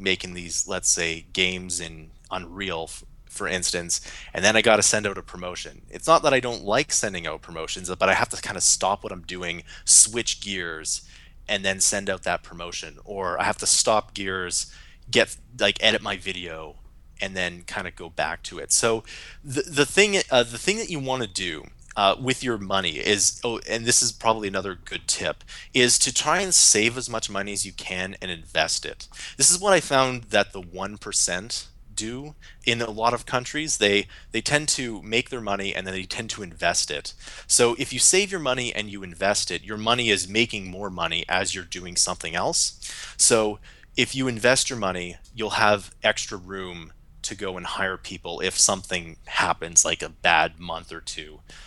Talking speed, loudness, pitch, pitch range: 205 wpm, -22 LUFS, 100 Hz, 90-115 Hz